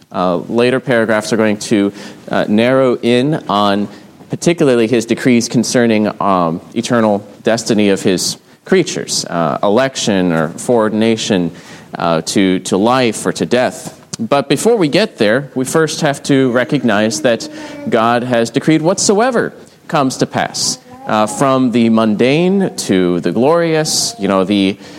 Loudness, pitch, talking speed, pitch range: -14 LUFS, 115 Hz, 140 wpm, 105-135 Hz